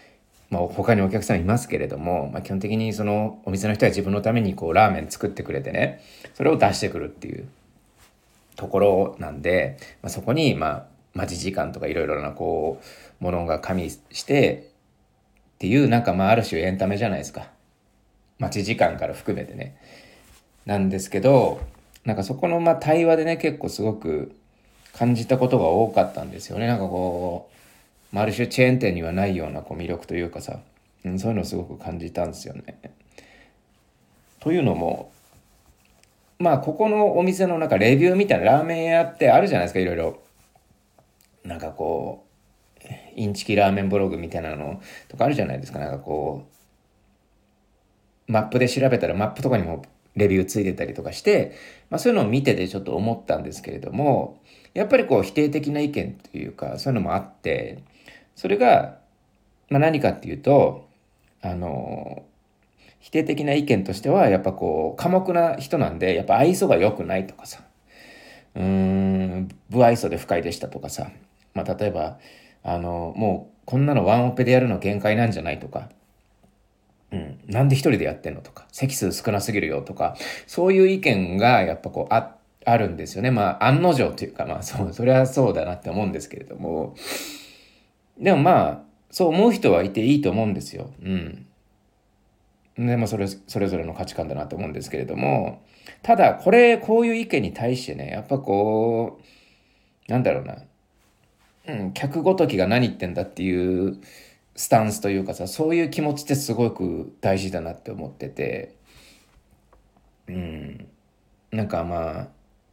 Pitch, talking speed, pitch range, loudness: 105 Hz, 355 characters per minute, 95-130 Hz, -22 LUFS